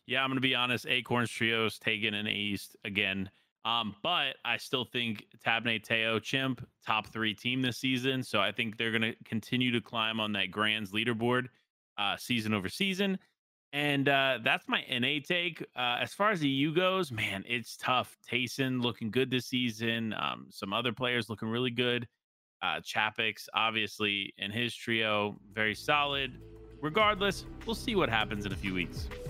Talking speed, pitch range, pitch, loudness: 175 wpm, 110-130 Hz, 120 Hz, -31 LUFS